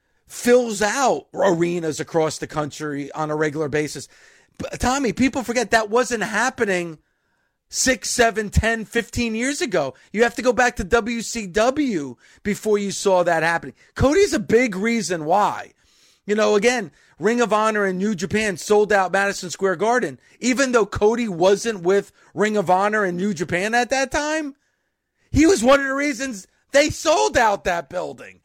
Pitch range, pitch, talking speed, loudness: 185-245 Hz, 215 Hz, 165 wpm, -20 LUFS